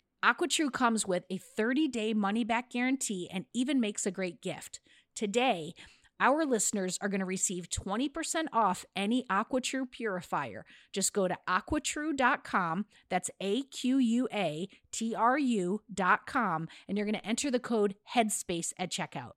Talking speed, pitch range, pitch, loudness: 150 wpm, 190-250 Hz, 215 Hz, -31 LUFS